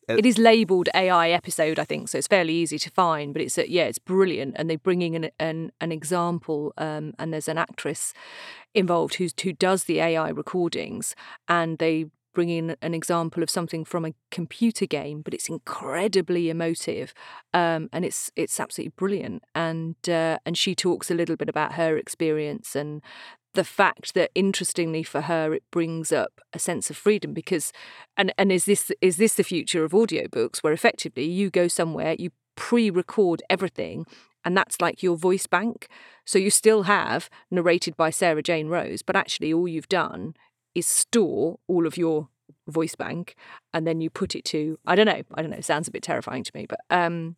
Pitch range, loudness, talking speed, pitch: 160-185 Hz, -24 LUFS, 195 wpm, 170 Hz